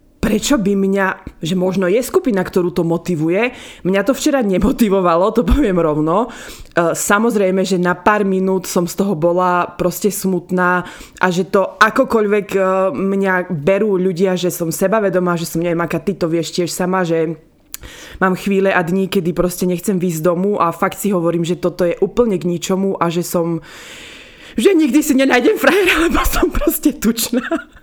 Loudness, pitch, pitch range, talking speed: -16 LUFS, 190 Hz, 180-215 Hz, 175 wpm